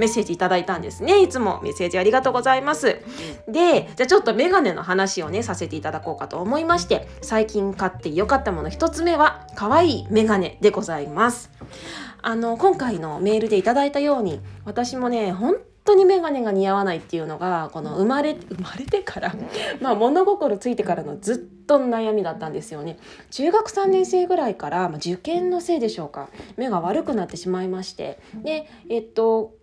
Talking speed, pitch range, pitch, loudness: 405 characters per minute, 190-305 Hz, 225 Hz, -21 LUFS